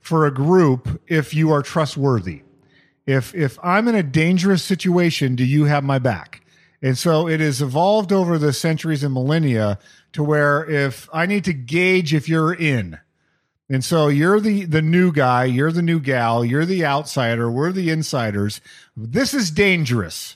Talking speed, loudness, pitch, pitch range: 175 wpm, -18 LUFS, 150 Hz, 135-170 Hz